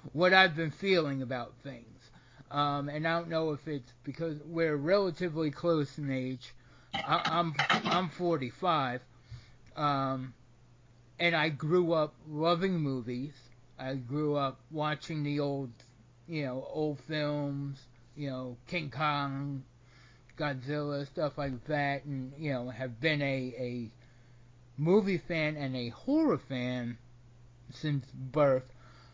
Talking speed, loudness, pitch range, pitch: 130 wpm, -32 LUFS, 125-155 Hz, 140 Hz